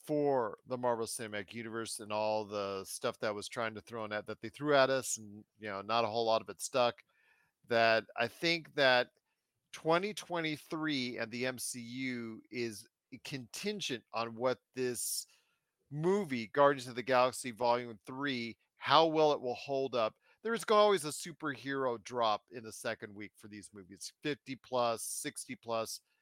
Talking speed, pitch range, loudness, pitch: 165 wpm, 110-135 Hz, -34 LUFS, 120 Hz